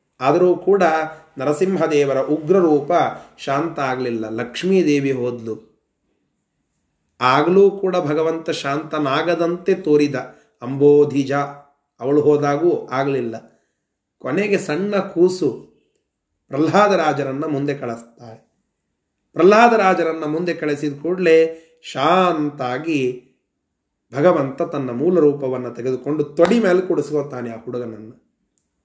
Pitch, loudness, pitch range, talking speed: 145 Hz, -18 LUFS, 130-165 Hz, 80 wpm